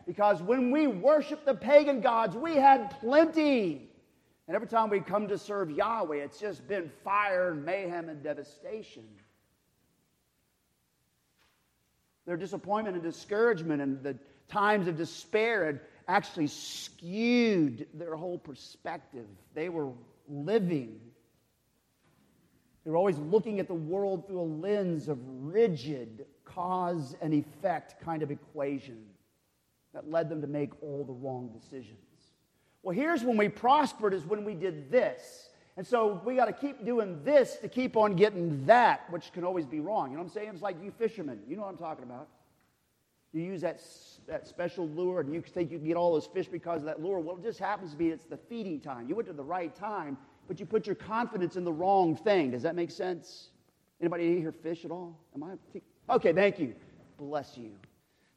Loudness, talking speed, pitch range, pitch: -31 LUFS, 180 wpm, 150-205 Hz, 175 Hz